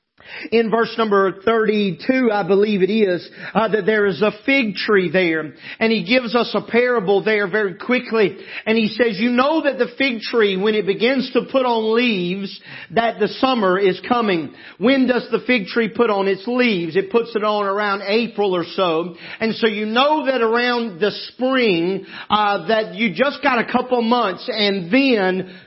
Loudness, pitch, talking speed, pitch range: -18 LUFS, 220 Hz, 190 wpm, 195-240 Hz